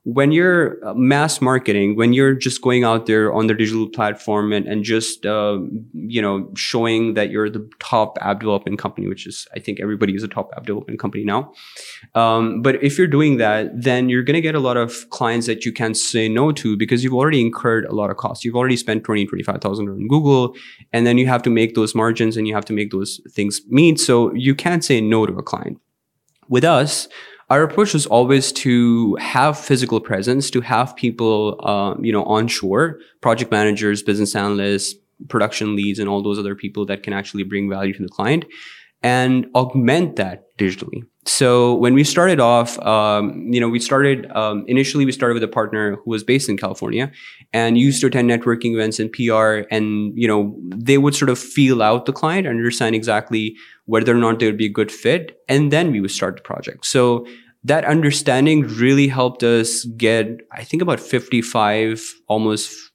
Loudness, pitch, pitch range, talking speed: -18 LUFS, 115 Hz, 105-130 Hz, 200 wpm